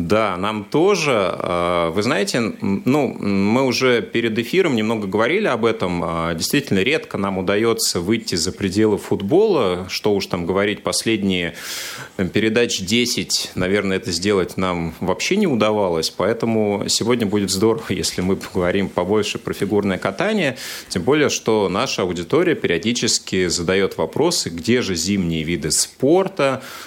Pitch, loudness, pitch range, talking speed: 100 Hz, -19 LUFS, 90-110 Hz, 135 wpm